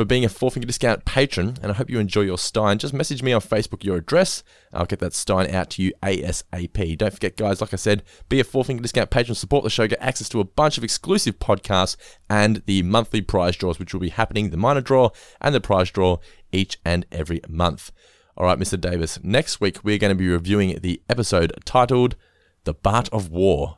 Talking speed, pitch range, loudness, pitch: 230 wpm, 90-115 Hz, -22 LUFS, 100 Hz